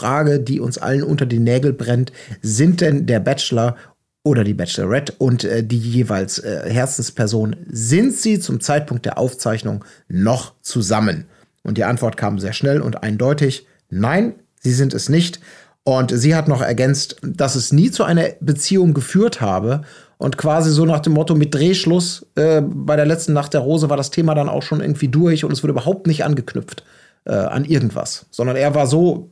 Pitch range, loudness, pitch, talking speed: 120-155 Hz, -17 LUFS, 140 Hz, 185 wpm